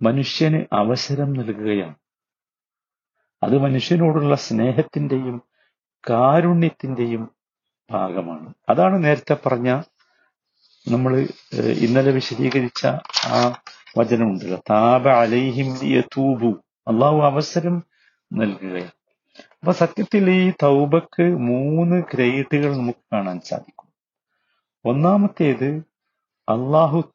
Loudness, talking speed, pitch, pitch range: -19 LUFS, 75 wpm, 135 Hz, 120-155 Hz